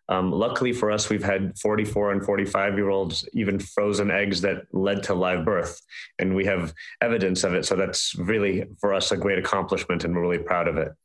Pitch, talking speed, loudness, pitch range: 100 Hz, 210 wpm, -24 LUFS, 95-100 Hz